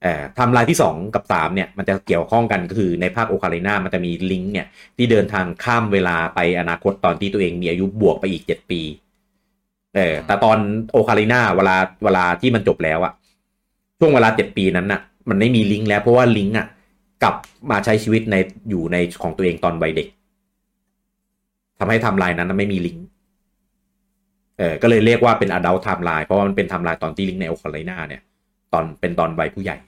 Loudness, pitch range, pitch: -18 LUFS, 90-120 Hz, 100 Hz